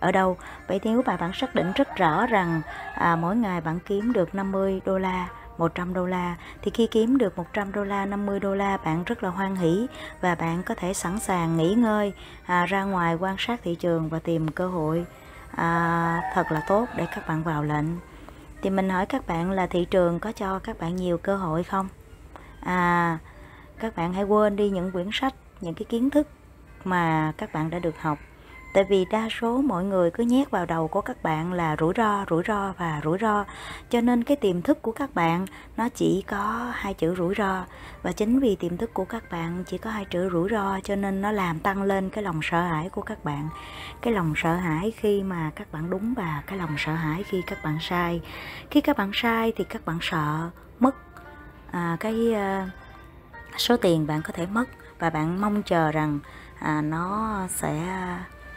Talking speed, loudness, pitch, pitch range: 215 wpm, -26 LUFS, 185 Hz, 170-210 Hz